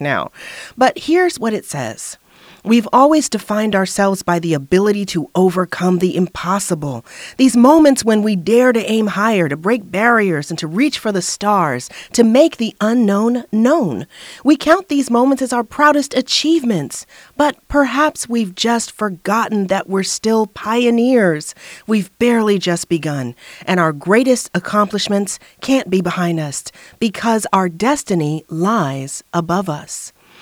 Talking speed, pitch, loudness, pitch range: 145 wpm, 215 Hz, -15 LUFS, 180-240 Hz